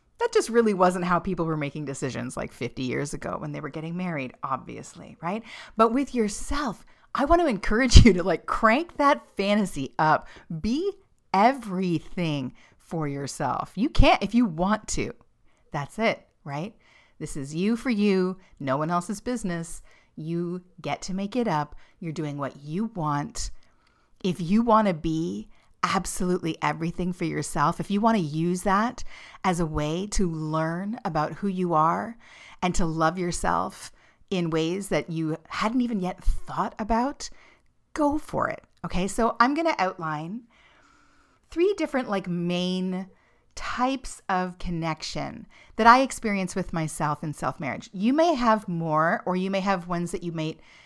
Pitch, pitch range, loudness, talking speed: 185 Hz, 160-220 Hz, -26 LUFS, 165 wpm